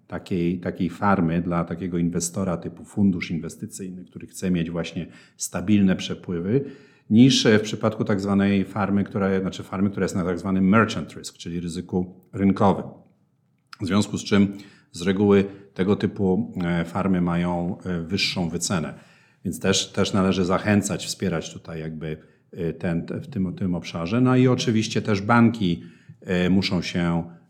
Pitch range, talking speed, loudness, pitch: 85-100 Hz, 155 wpm, -23 LUFS, 95 Hz